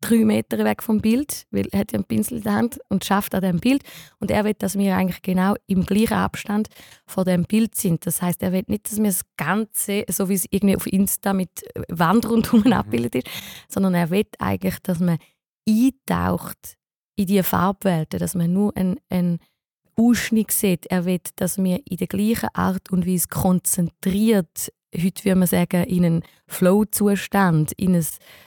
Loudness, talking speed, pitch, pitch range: -21 LUFS, 190 wpm, 190 Hz, 175-210 Hz